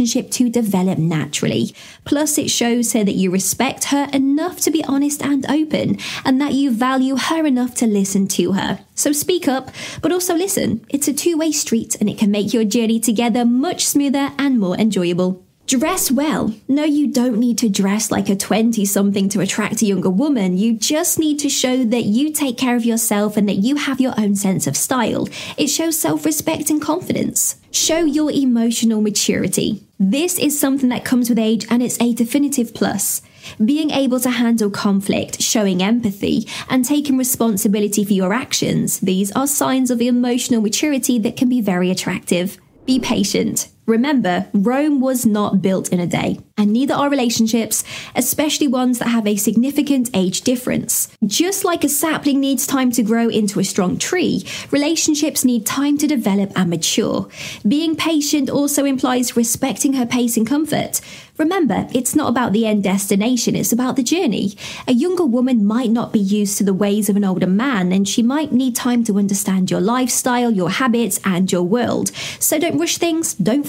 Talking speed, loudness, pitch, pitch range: 185 wpm, -17 LUFS, 245 Hz, 210-280 Hz